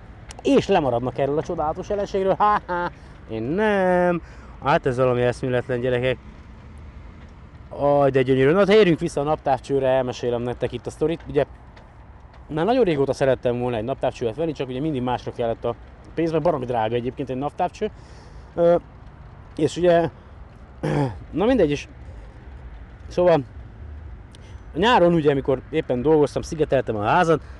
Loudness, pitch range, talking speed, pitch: -22 LUFS, 120-165 Hz, 140 wpm, 135 Hz